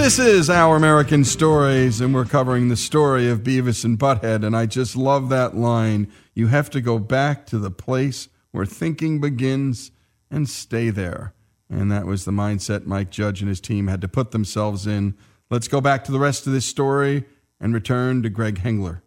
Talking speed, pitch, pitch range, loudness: 200 wpm, 120 Hz, 105-135 Hz, -20 LUFS